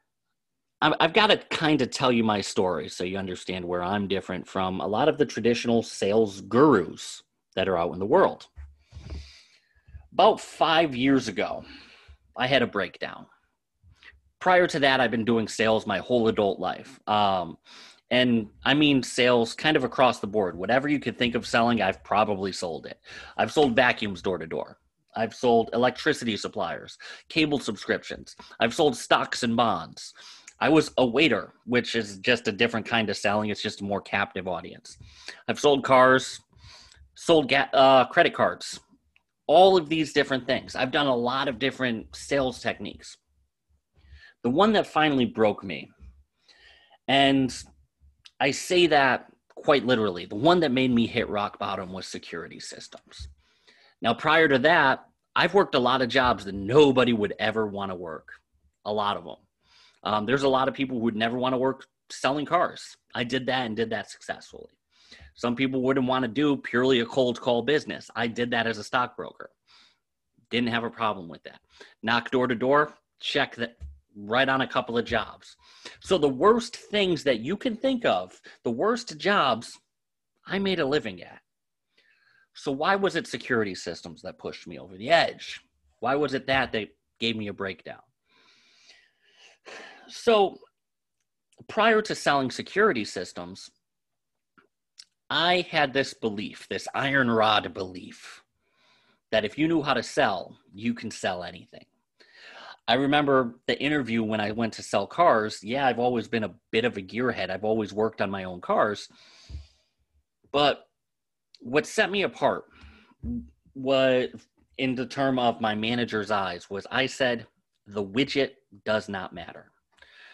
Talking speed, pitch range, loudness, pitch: 165 wpm, 105-135 Hz, -25 LUFS, 120 Hz